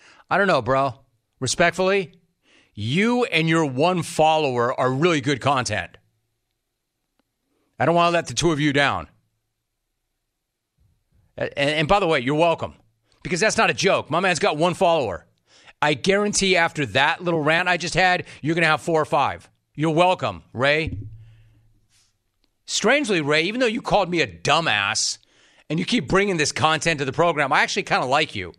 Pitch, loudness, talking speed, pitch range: 155 Hz, -20 LUFS, 175 wpm, 125-175 Hz